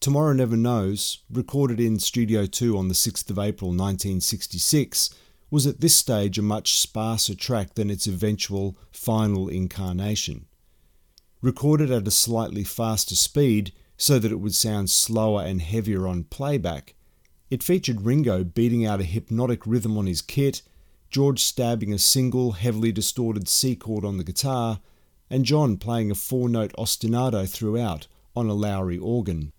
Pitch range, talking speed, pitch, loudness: 95-120 Hz, 150 wpm, 110 Hz, -23 LUFS